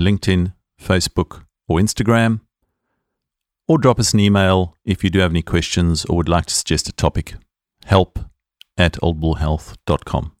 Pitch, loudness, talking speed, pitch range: 95 Hz, -18 LUFS, 145 wpm, 85-100 Hz